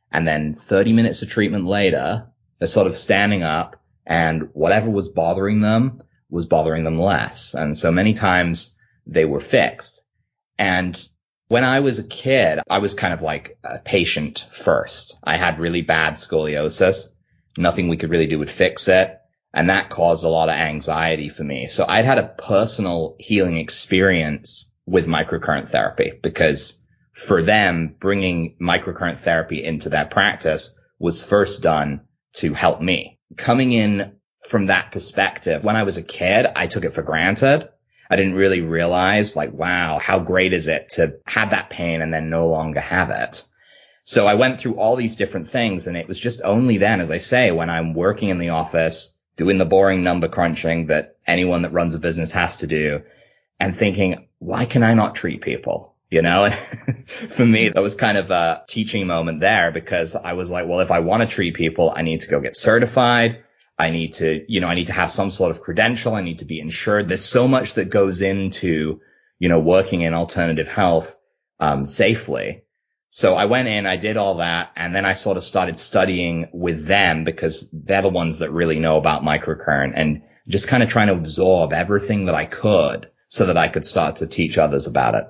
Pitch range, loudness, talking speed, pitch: 80-100 Hz, -19 LUFS, 195 wpm, 90 Hz